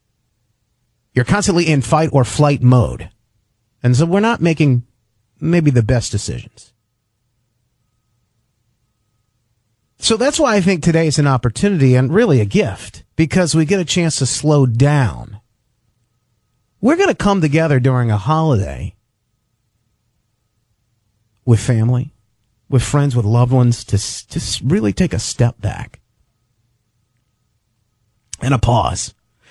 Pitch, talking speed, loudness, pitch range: 120 Hz, 125 wpm, -15 LUFS, 115-140 Hz